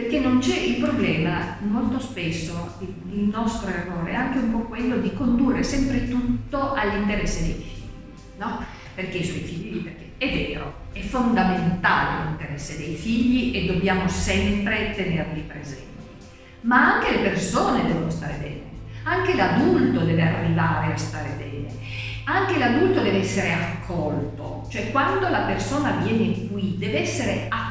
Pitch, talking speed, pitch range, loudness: 180 Hz, 145 wpm, 140-230 Hz, -23 LUFS